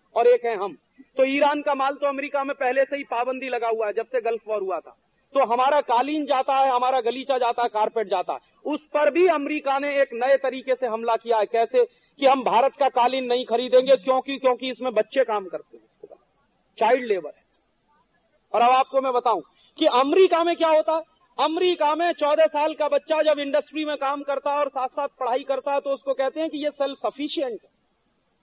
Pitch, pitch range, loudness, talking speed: 270 Hz, 250-295 Hz, -23 LUFS, 215 wpm